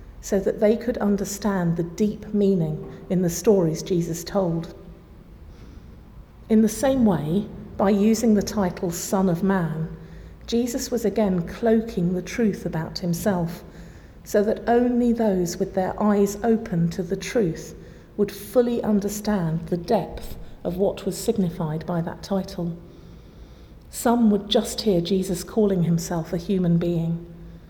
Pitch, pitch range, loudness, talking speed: 195 Hz, 175-210 Hz, -23 LUFS, 140 wpm